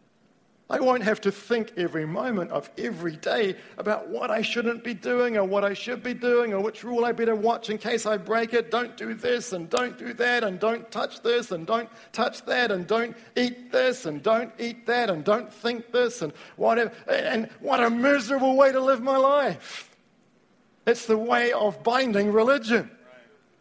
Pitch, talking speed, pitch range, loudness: 230 Hz, 195 wpm, 215-245 Hz, -25 LUFS